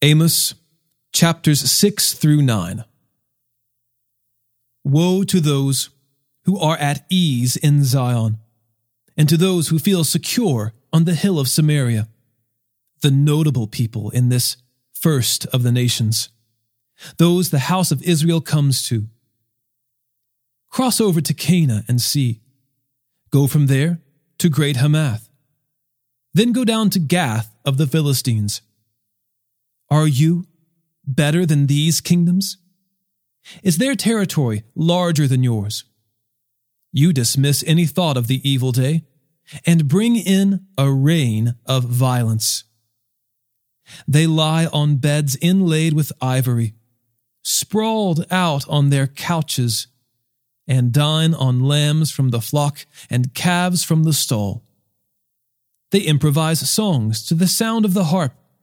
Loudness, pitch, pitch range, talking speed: -17 LUFS, 140 Hz, 120-160 Hz, 125 wpm